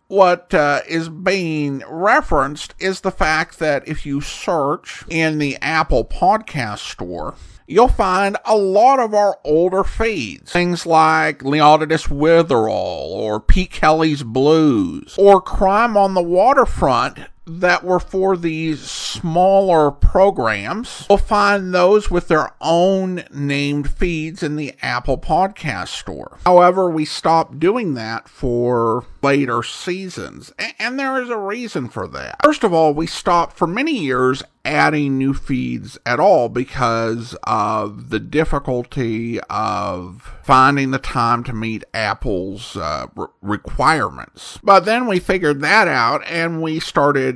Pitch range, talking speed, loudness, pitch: 140-190 Hz, 135 wpm, -17 LUFS, 160 Hz